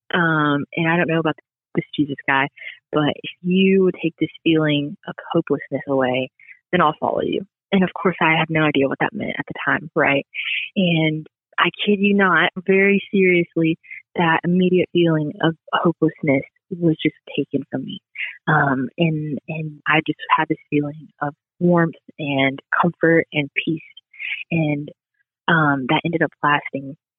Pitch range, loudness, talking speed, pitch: 145-175 Hz, -20 LUFS, 165 wpm, 160 Hz